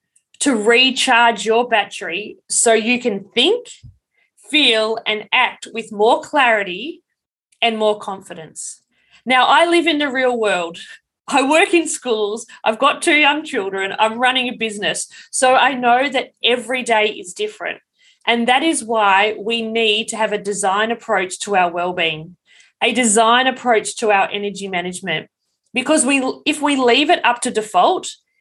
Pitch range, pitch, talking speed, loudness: 210-275 Hz, 235 Hz, 160 wpm, -16 LUFS